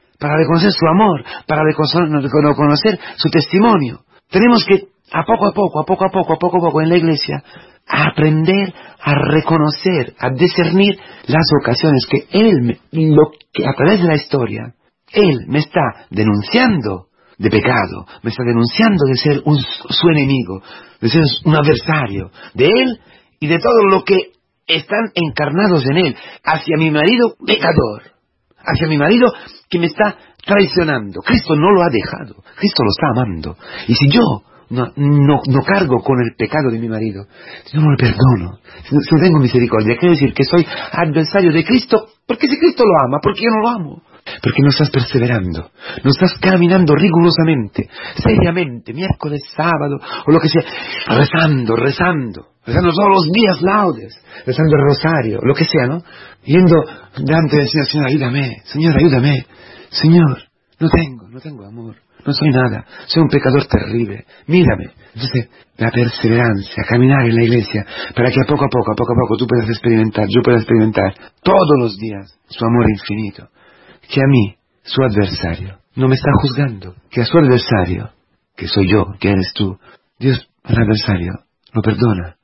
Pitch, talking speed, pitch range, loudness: 145 Hz, 170 wpm, 120-170 Hz, -14 LUFS